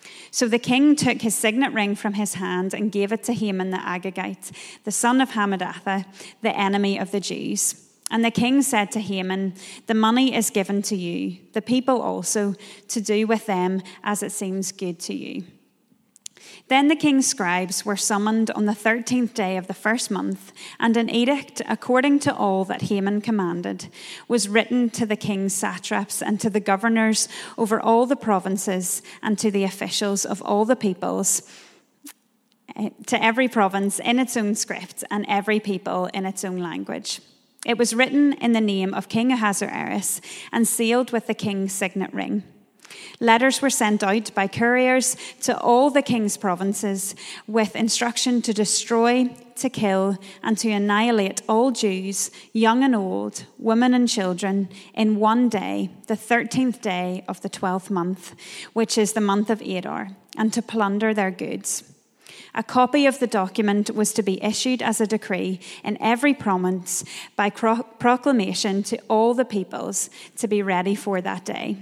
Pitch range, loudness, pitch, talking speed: 195-235 Hz, -22 LUFS, 215 Hz, 170 wpm